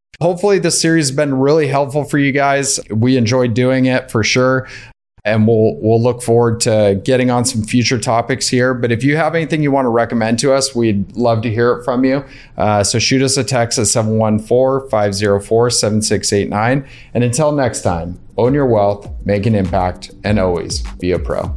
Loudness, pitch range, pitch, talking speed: -14 LUFS, 110-135 Hz, 120 Hz, 200 wpm